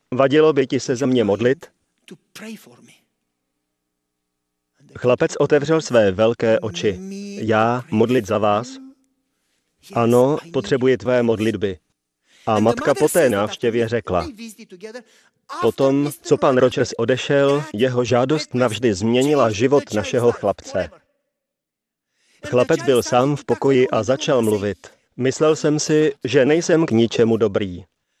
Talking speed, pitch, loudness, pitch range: 115 wpm, 125 Hz, -18 LUFS, 110-145 Hz